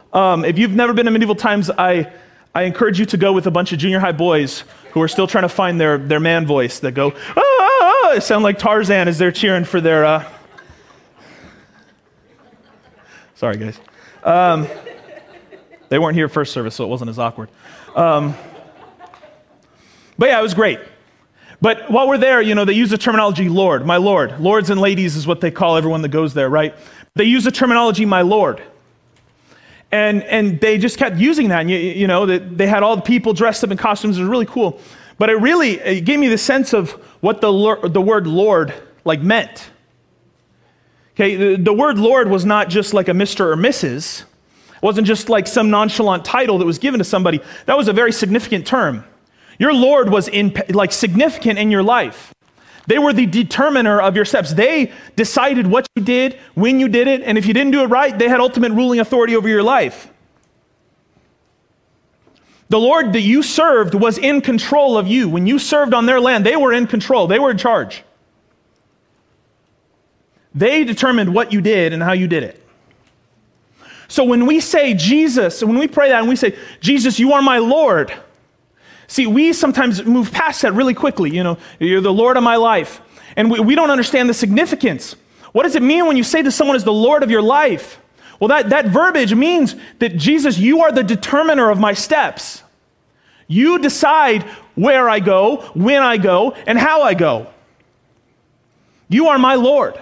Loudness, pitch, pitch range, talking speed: -14 LUFS, 220 Hz, 190-255 Hz, 195 wpm